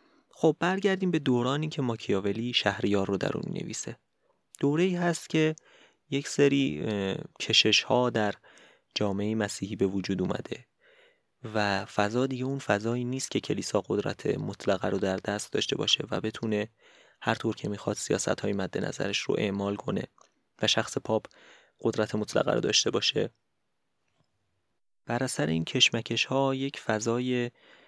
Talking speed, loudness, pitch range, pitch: 140 wpm, -28 LUFS, 105-140 Hz, 115 Hz